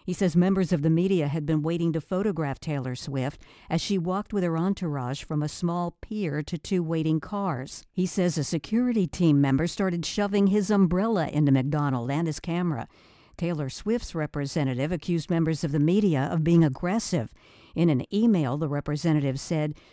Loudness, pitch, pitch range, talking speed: -26 LUFS, 165 Hz, 150-185 Hz, 180 wpm